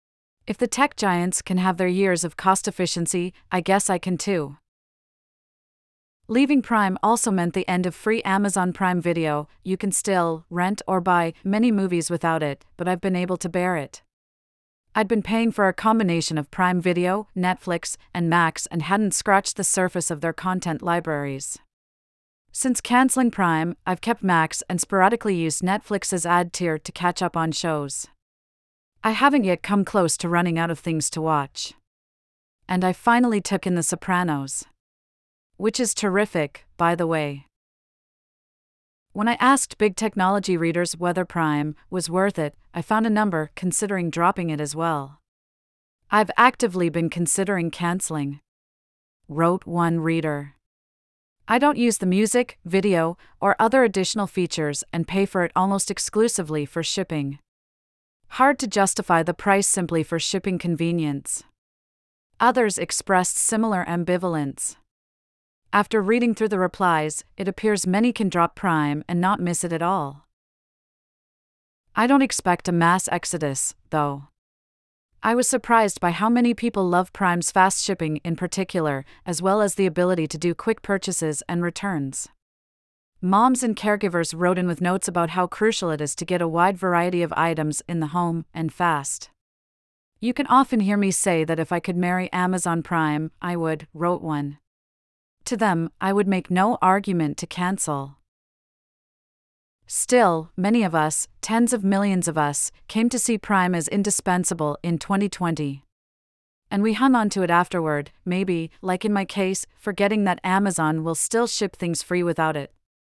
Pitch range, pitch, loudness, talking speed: 160-200 Hz, 180 Hz, -22 LUFS, 160 wpm